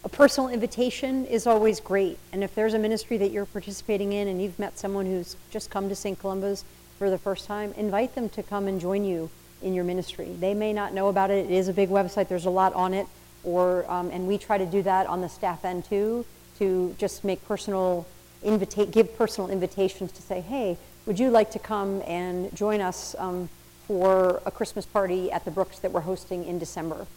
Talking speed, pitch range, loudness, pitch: 220 wpm, 185-210 Hz, -27 LUFS, 195 Hz